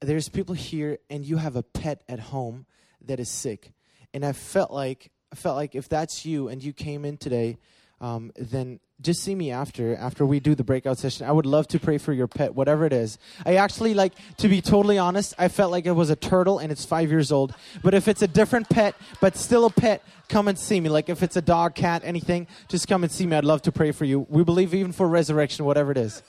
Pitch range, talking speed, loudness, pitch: 140-180 Hz, 255 wpm, -24 LUFS, 155 Hz